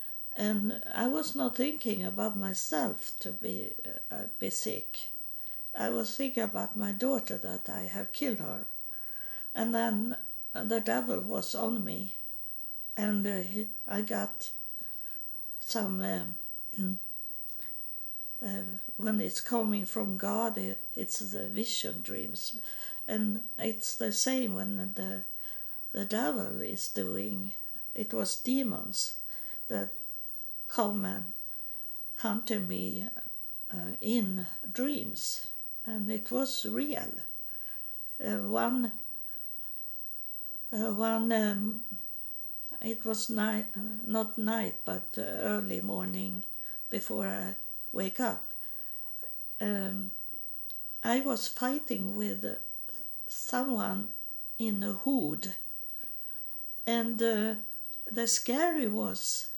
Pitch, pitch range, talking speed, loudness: 220 Hz, 200-235 Hz, 105 wpm, -33 LUFS